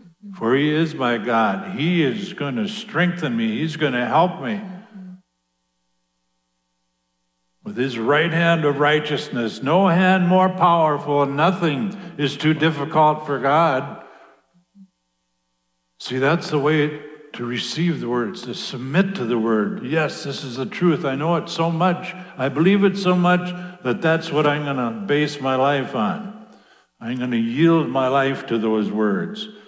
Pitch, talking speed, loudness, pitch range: 150 Hz, 160 wpm, -20 LUFS, 125-180 Hz